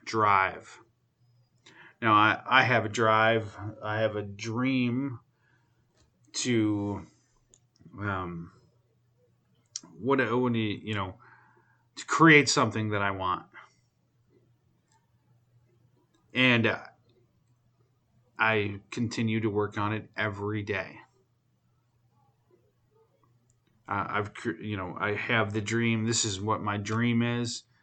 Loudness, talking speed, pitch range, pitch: -27 LUFS, 100 wpm, 110-120 Hz, 115 Hz